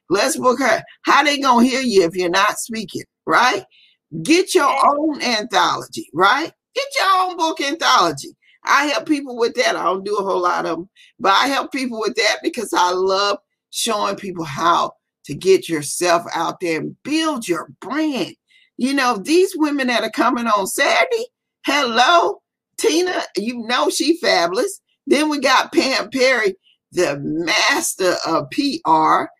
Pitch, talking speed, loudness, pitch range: 265 Hz, 165 wpm, -18 LUFS, 200-330 Hz